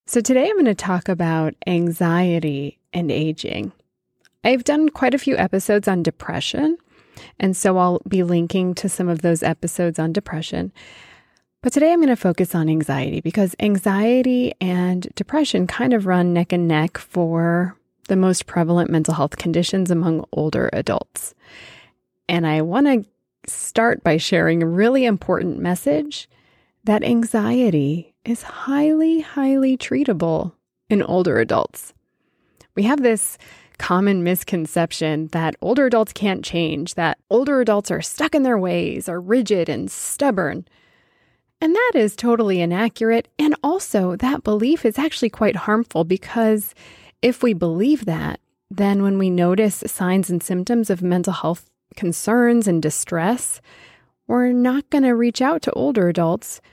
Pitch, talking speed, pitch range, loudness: 195 Hz, 145 wpm, 170-240 Hz, -19 LUFS